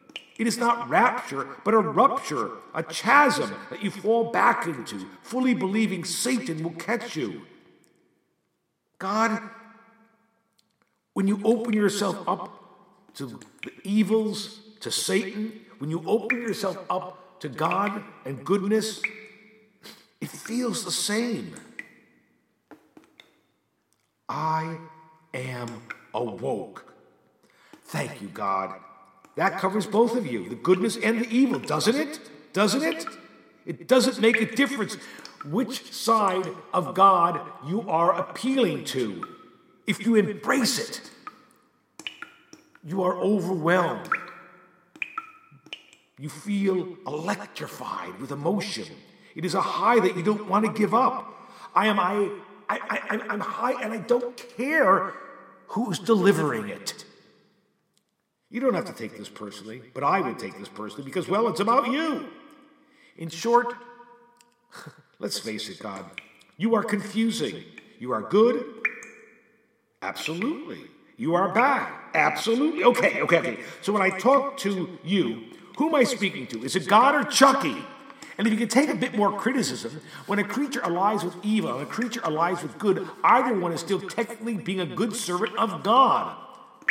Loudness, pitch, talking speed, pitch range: -25 LUFS, 220 Hz, 140 wpm, 185-240 Hz